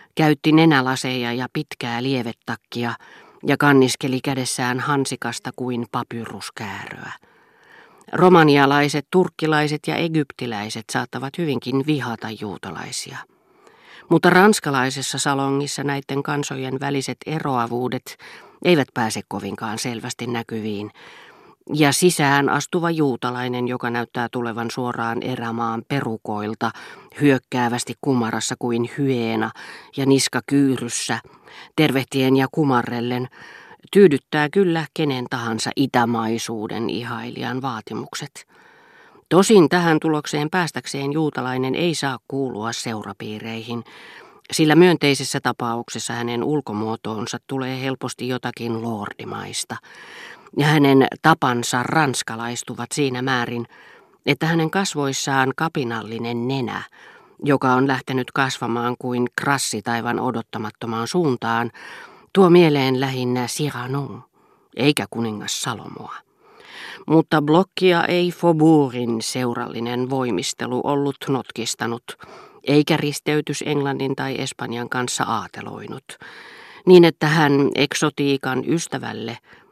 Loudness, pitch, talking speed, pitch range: -20 LUFS, 130 Hz, 95 wpm, 120-150 Hz